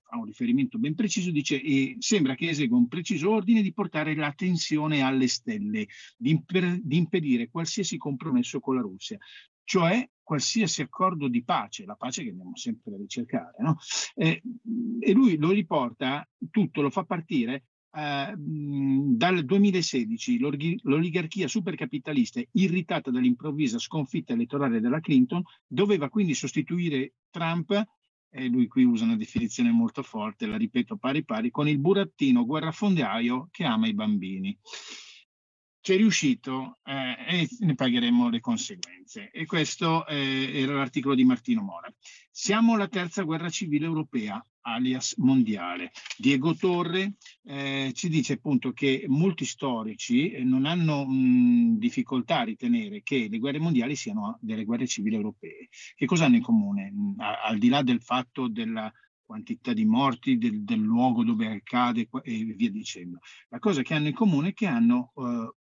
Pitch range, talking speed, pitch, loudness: 145-230 Hz, 150 wpm, 195 Hz, -26 LUFS